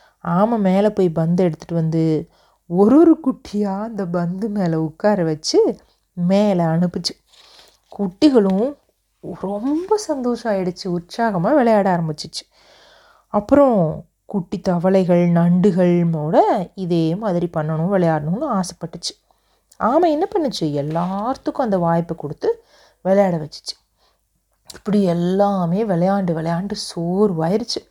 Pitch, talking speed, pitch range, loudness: 190 Hz, 100 wpm, 170-215 Hz, -19 LUFS